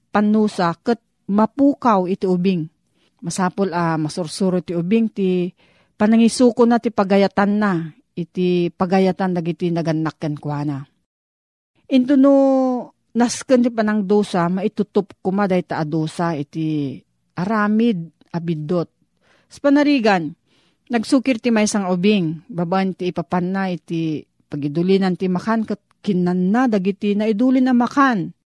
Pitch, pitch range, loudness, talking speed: 190 Hz, 170-220 Hz, -19 LUFS, 130 wpm